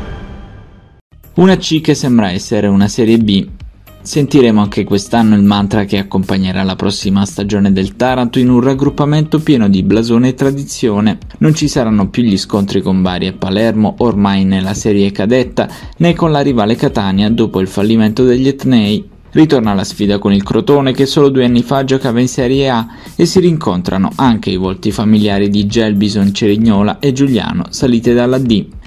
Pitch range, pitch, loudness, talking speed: 100-135 Hz, 115 Hz, -12 LUFS, 170 wpm